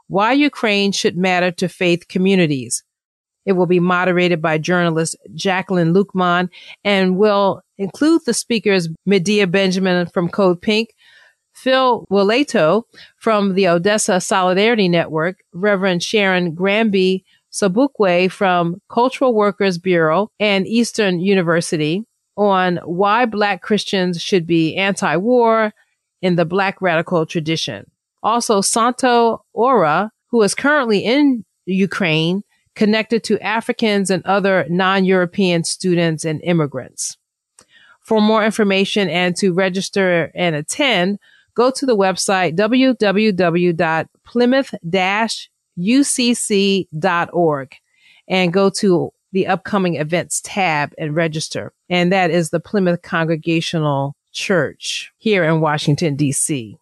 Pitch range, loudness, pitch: 175-210 Hz, -17 LUFS, 190 Hz